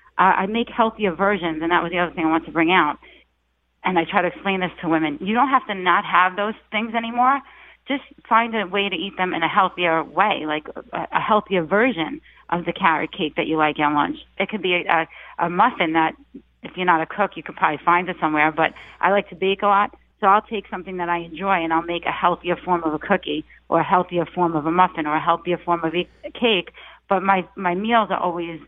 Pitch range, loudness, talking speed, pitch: 165-200 Hz, -21 LUFS, 250 wpm, 180 Hz